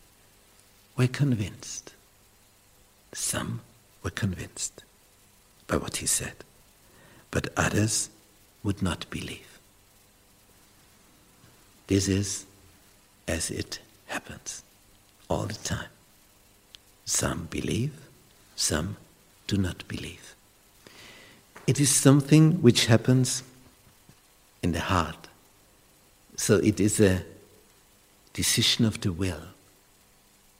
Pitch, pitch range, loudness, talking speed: 100 Hz, 100-110 Hz, -26 LUFS, 85 wpm